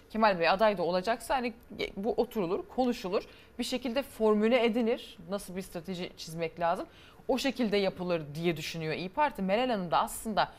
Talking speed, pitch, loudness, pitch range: 165 wpm, 210 Hz, -31 LUFS, 180-240 Hz